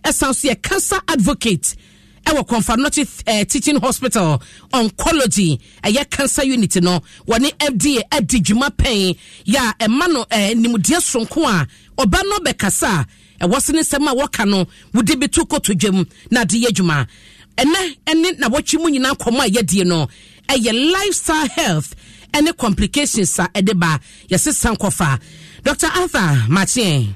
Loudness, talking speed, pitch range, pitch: -16 LUFS, 170 wpm, 190-290 Hz, 235 Hz